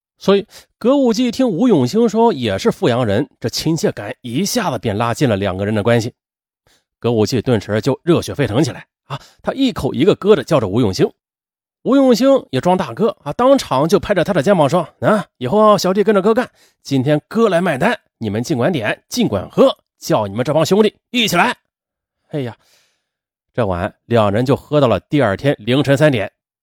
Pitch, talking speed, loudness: 155 Hz, 285 characters per minute, -16 LUFS